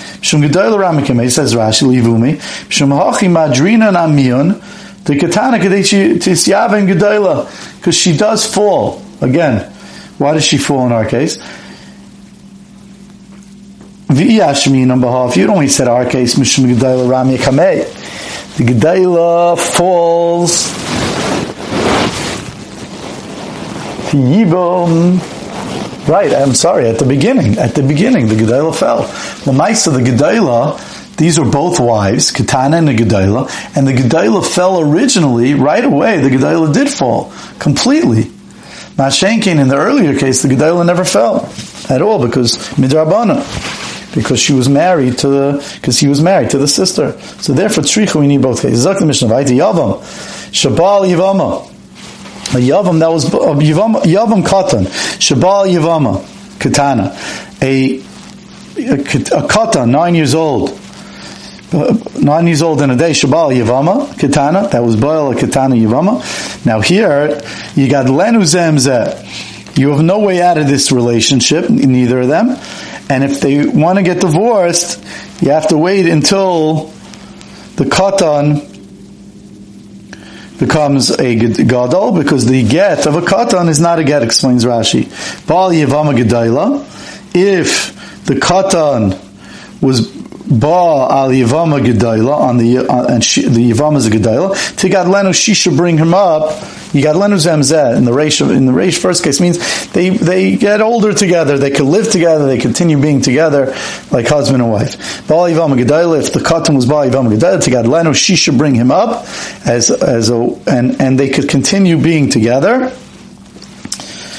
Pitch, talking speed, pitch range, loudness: 150 Hz, 140 wpm, 130-180 Hz, -10 LUFS